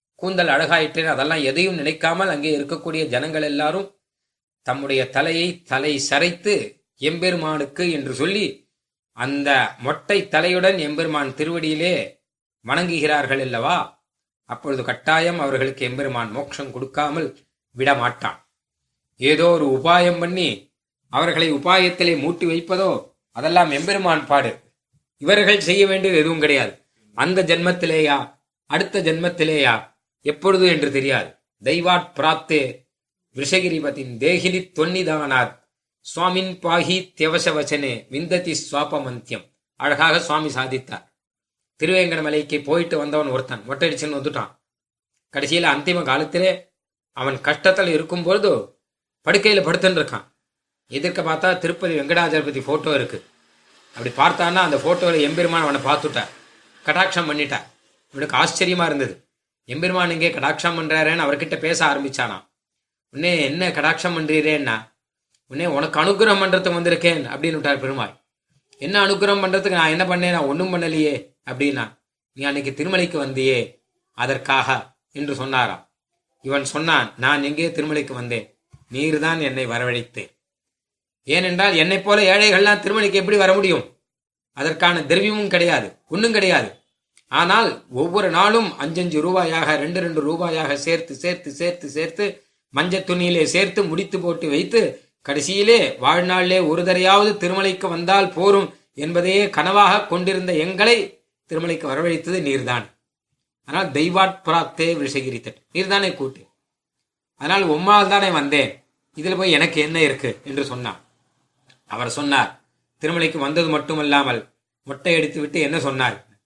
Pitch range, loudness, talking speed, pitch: 140-180 Hz, -19 LUFS, 110 wpm, 160 Hz